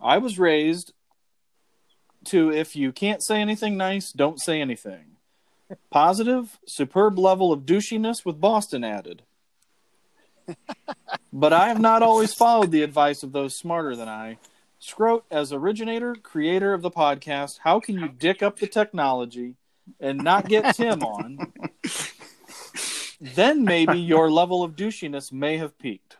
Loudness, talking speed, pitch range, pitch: -22 LUFS, 140 wpm, 145-215 Hz, 180 Hz